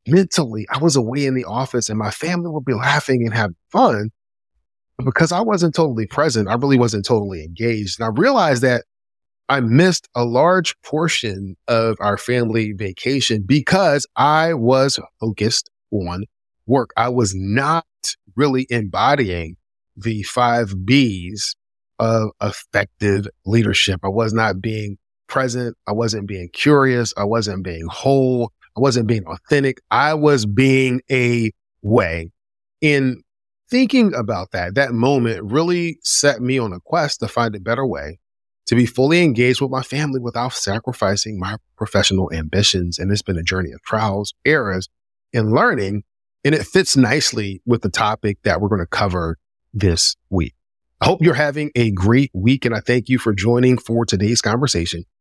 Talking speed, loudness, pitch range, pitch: 160 wpm, -18 LUFS, 100-130 Hz, 115 Hz